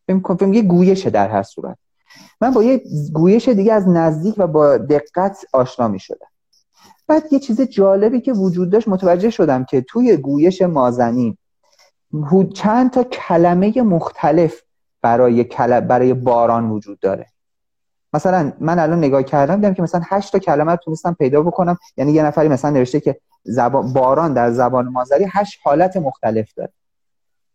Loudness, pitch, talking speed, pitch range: -15 LUFS, 170 Hz, 150 wpm, 135-195 Hz